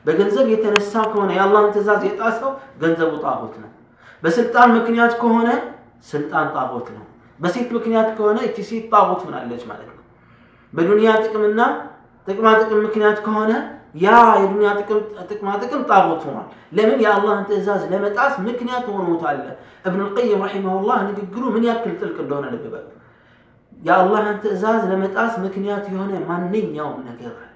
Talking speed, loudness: 145 wpm, -18 LUFS